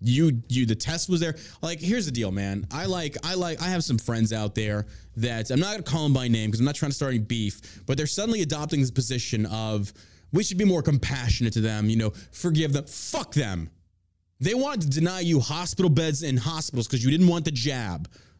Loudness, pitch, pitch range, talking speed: -26 LUFS, 135 Hz, 110-160 Hz, 235 wpm